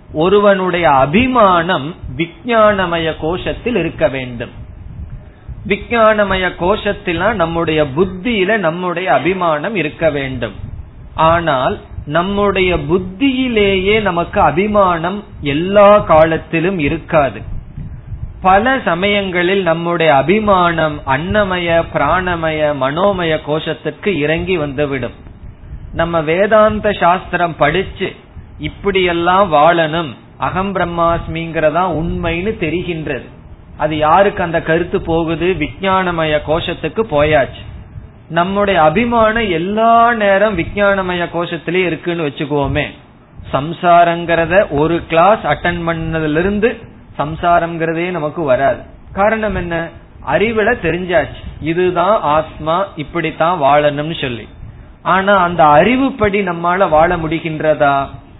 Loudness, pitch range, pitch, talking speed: -14 LUFS, 155-195 Hz, 170 Hz, 85 wpm